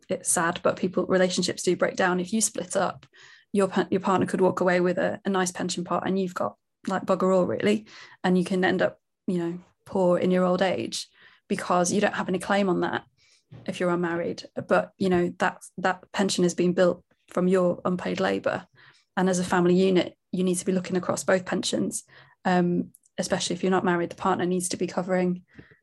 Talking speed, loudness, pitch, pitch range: 215 wpm, -25 LUFS, 185 Hz, 180-190 Hz